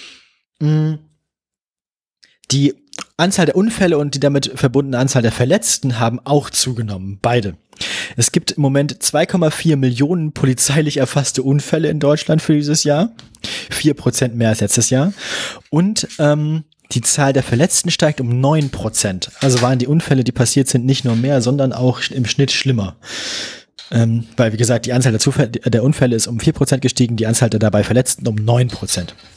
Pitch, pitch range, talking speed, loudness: 135 Hz, 120-150 Hz, 160 wpm, -16 LUFS